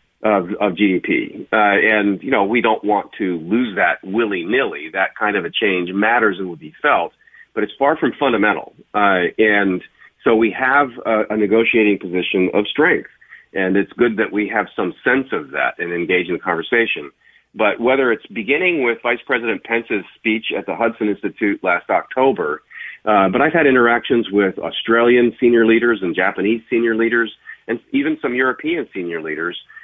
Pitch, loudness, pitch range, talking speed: 110 Hz, -17 LUFS, 100-120 Hz, 195 wpm